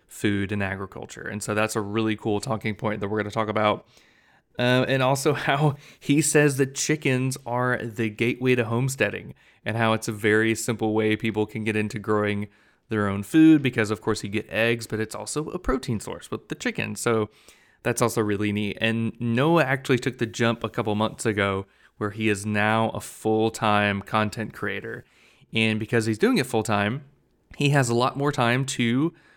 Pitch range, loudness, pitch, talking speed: 105-125 Hz, -24 LUFS, 110 Hz, 200 wpm